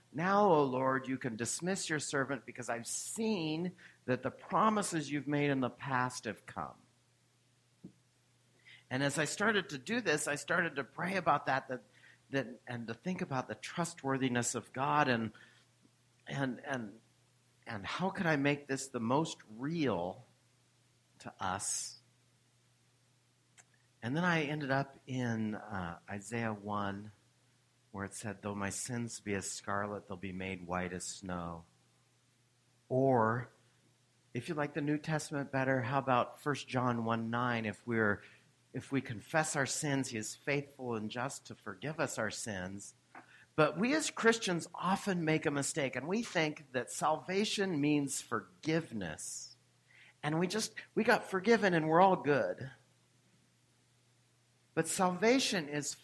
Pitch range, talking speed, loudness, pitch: 120-150 Hz, 150 wpm, -35 LUFS, 130 Hz